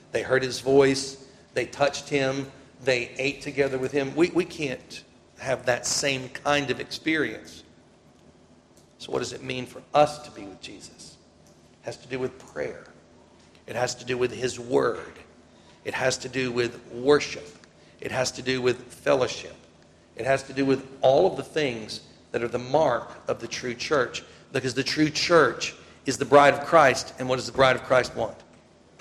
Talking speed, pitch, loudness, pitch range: 190 wpm, 130 Hz, -25 LUFS, 125-140 Hz